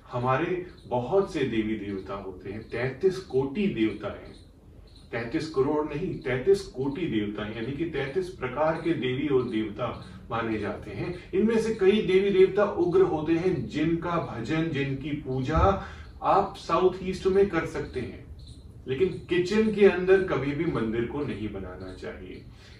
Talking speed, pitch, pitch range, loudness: 155 wpm, 145 Hz, 110-185 Hz, -27 LUFS